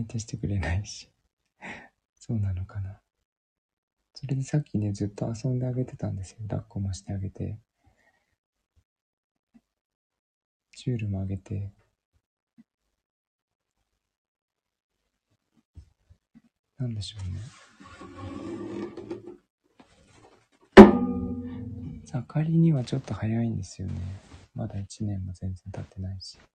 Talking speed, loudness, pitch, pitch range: 200 characters per minute, -26 LUFS, 105 Hz, 95-115 Hz